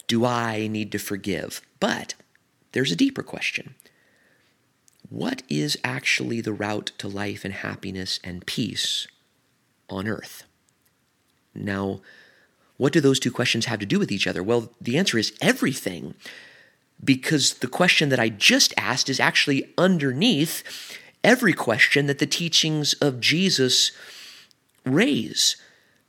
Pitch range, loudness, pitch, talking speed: 100-145 Hz, -22 LUFS, 120 Hz, 135 wpm